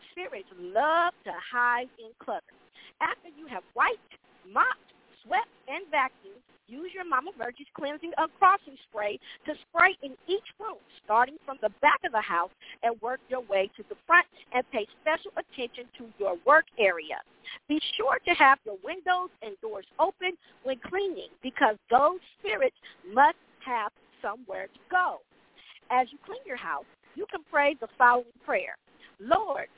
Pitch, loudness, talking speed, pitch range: 295 Hz, -28 LUFS, 160 wpm, 245-360 Hz